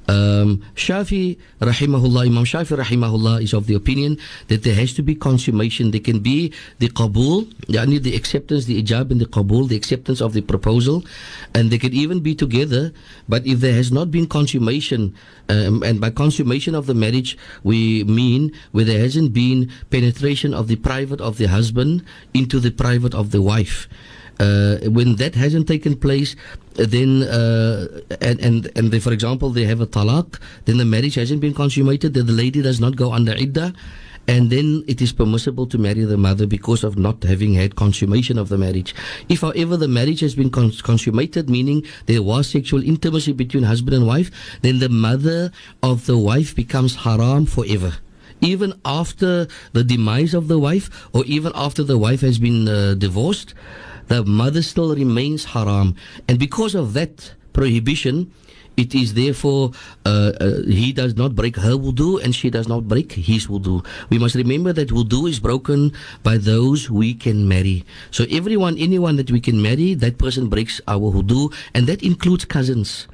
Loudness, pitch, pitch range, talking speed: -18 LUFS, 125 Hz, 110-145 Hz, 180 wpm